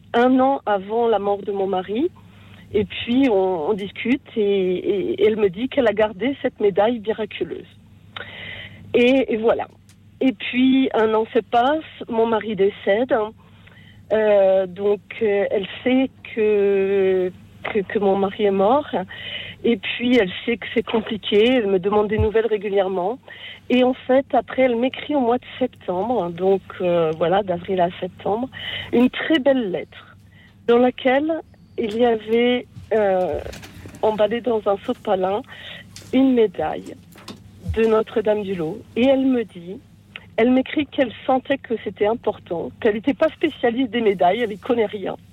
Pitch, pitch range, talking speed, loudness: 220 Hz, 200-250 Hz, 160 wpm, -20 LUFS